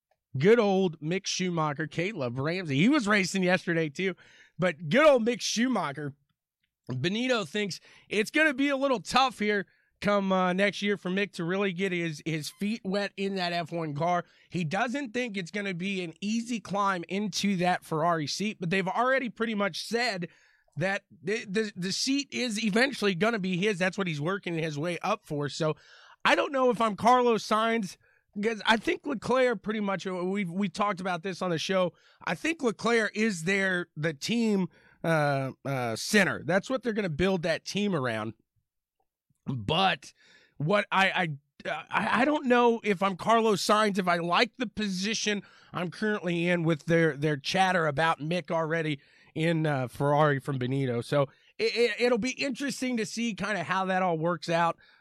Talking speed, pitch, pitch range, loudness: 185 wpm, 195 Hz, 170-220 Hz, -28 LUFS